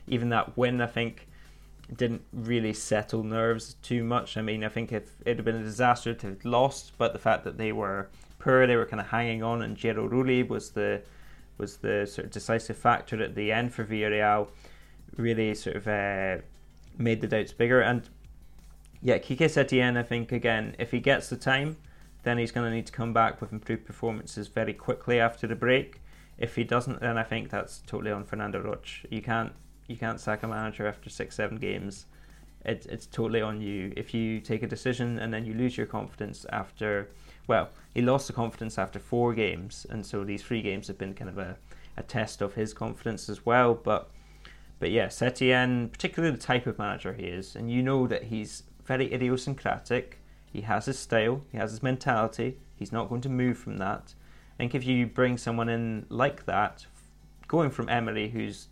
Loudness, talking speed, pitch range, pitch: -29 LUFS, 205 wpm, 105-120 Hz, 115 Hz